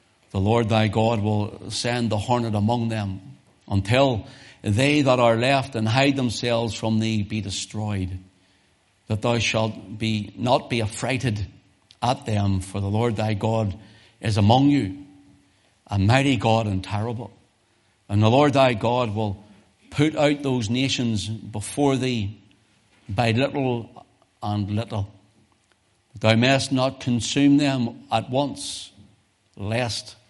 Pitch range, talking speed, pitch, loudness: 100-120 Hz, 135 wpm, 110 Hz, -23 LUFS